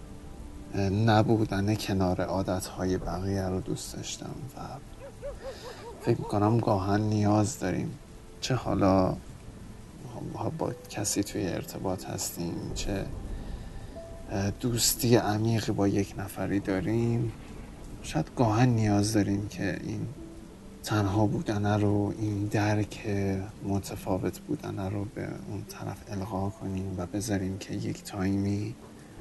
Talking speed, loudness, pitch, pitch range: 105 wpm, -29 LUFS, 100 Hz, 95-105 Hz